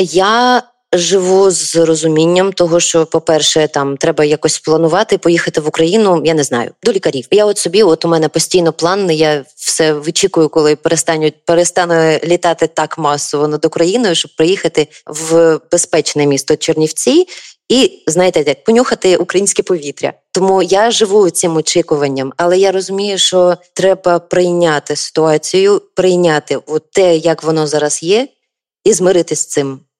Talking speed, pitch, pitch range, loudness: 145 wpm, 165 Hz, 155-185 Hz, -12 LUFS